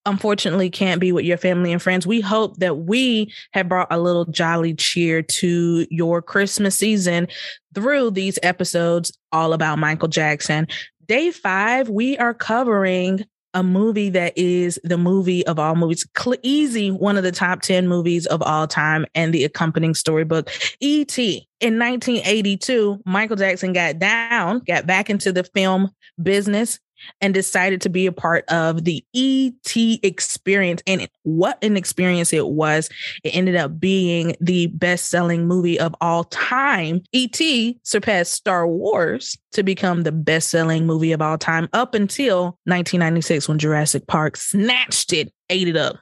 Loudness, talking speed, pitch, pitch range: -19 LUFS, 160 wpm, 180 Hz, 165-205 Hz